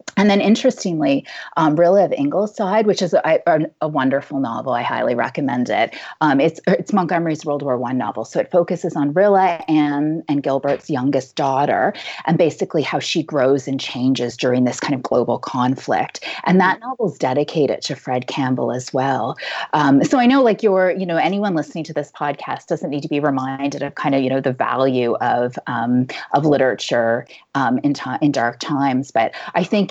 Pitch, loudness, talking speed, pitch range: 145 Hz, -18 LUFS, 195 wpm, 130-180 Hz